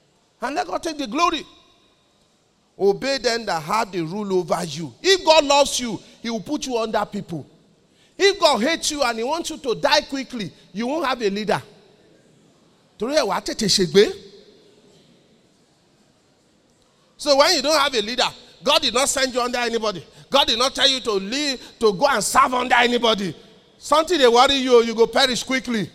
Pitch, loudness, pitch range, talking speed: 245 Hz, -19 LUFS, 210-285 Hz, 175 wpm